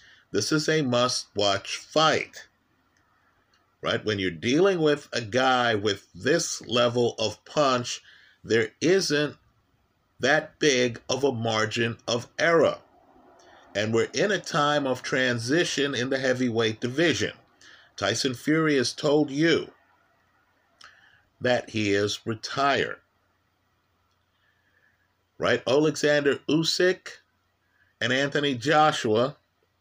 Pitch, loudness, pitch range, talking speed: 125 Hz, -25 LUFS, 110-145 Hz, 105 wpm